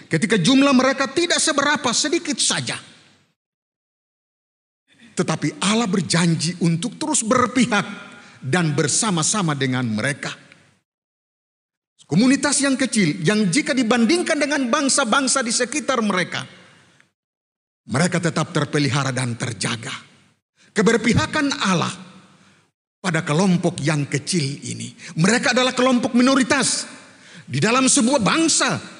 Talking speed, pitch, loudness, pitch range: 100 wpm, 205 Hz, -19 LUFS, 160-265 Hz